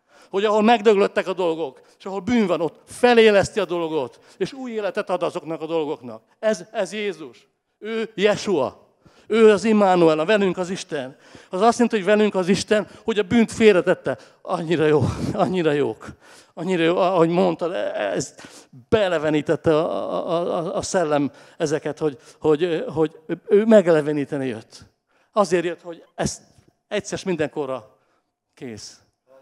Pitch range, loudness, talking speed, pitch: 155-210 Hz, -21 LUFS, 145 wpm, 180 Hz